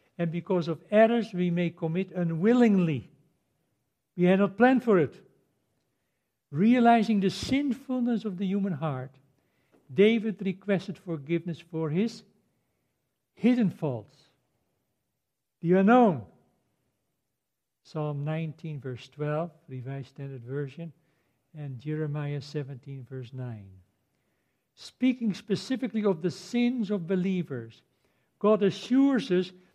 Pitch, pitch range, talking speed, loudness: 170 Hz, 140-205 Hz, 105 wpm, -27 LUFS